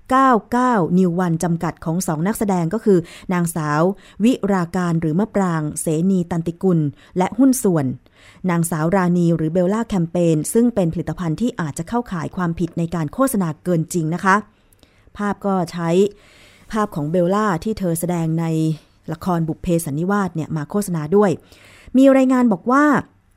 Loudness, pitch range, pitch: -19 LUFS, 160-200 Hz, 175 Hz